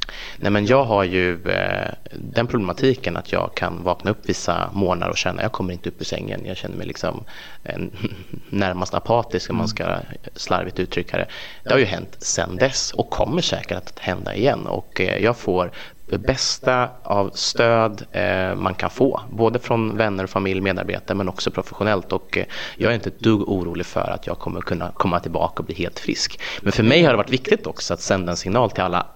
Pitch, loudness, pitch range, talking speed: 100 Hz, -22 LUFS, 90-115 Hz, 200 wpm